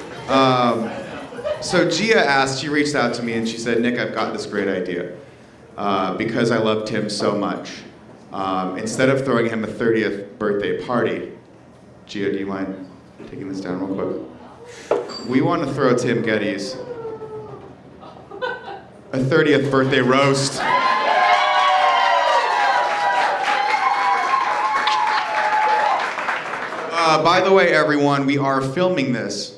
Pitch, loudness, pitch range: 120 Hz, -19 LUFS, 100-150 Hz